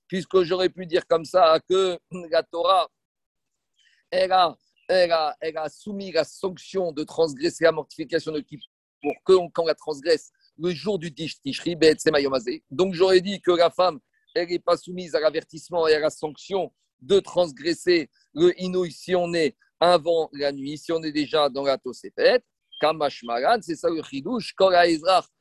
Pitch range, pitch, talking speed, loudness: 155-185 Hz, 170 Hz, 170 wpm, -23 LUFS